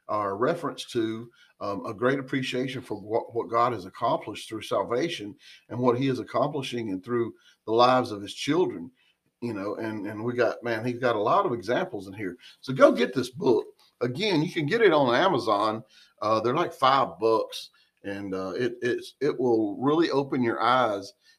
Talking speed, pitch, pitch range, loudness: 195 wpm, 125 Hz, 110-145 Hz, -26 LUFS